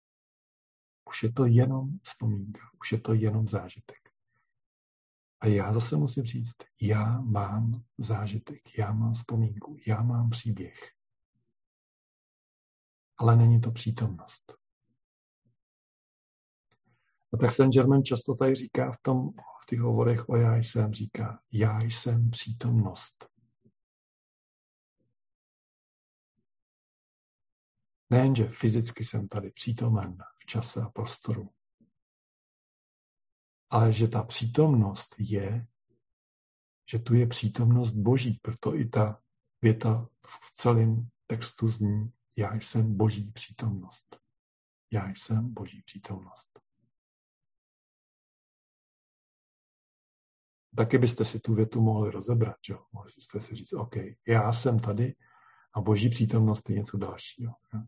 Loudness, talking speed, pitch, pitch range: -28 LUFS, 105 wpm, 115 Hz, 105-120 Hz